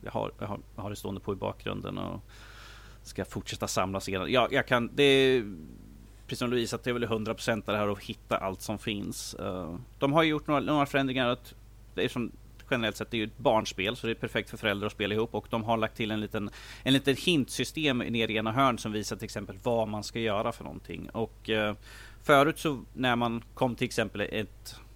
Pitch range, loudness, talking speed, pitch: 105-125 Hz, -30 LUFS, 205 wpm, 110 Hz